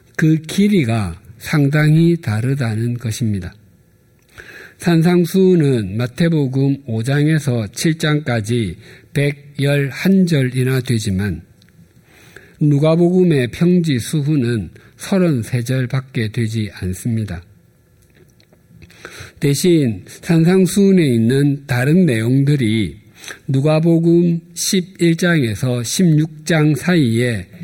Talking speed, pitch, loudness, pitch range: 175 characters per minute, 140 Hz, -16 LUFS, 115-165 Hz